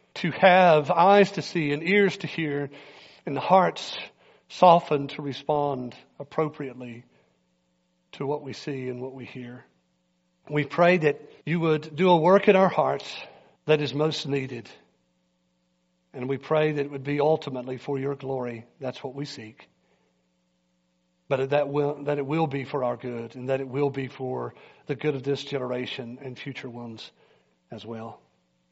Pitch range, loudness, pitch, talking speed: 115-150 Hz, -25 LUFS, 135 Hz, 165 wpm